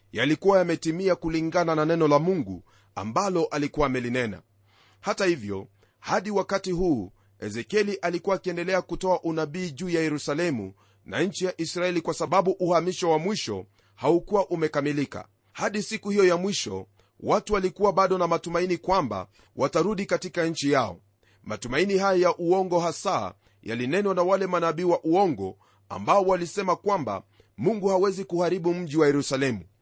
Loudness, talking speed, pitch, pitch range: -25 LUFS, 140 wpm, 165 Hz, 115-185 Hz